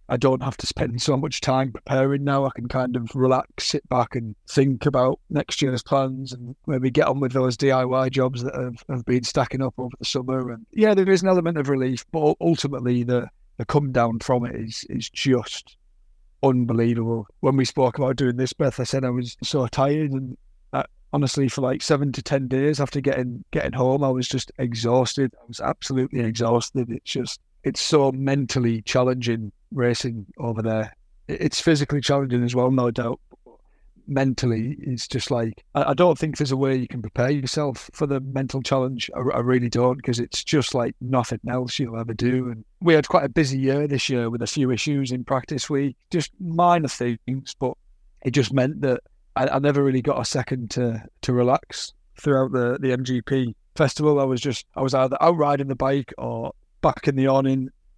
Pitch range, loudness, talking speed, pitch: 125-140 Hz, -23 LUFS, 200 wpm, 130 Hz